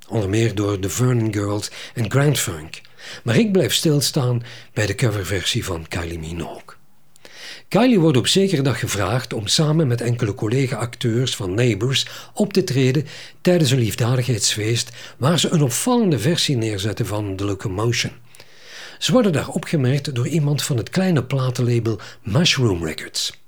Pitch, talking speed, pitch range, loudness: 125 Hz, 150 wpm, 110-145 Hz, -20 LUFS